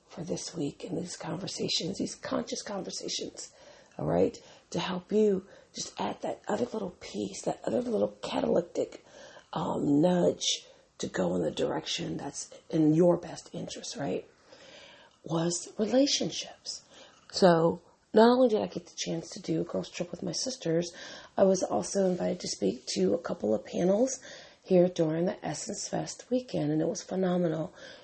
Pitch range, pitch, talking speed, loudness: 170-255 Hz, 185 Hz, 165 wpm, -30 LUFS